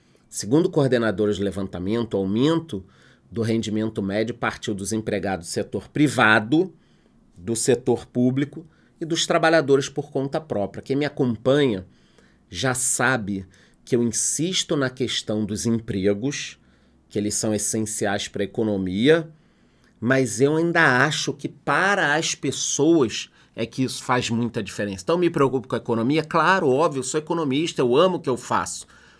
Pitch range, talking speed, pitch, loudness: 105-150 Hz, 150 wpm, 125 Hz, -22 LUFS